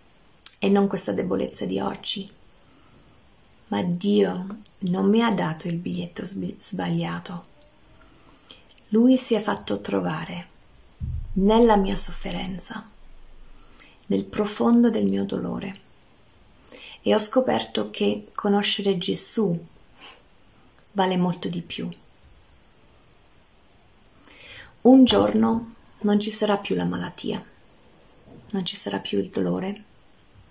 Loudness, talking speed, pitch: -23 LUFS, 100 wpm, 195 Hz